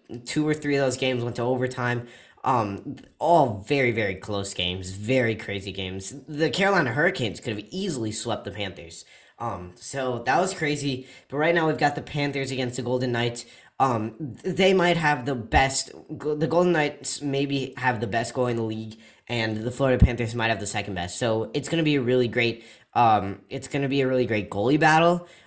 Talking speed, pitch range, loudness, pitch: 205 wpm, 115-145 Hz, -24 LUFS, 125 Hz